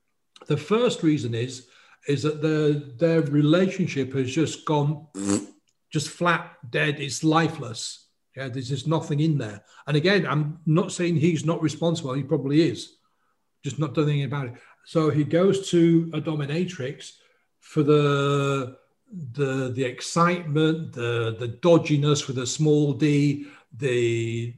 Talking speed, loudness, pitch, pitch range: 145 wpm, -24 LUFS, 150 Hz, 135-160 Hz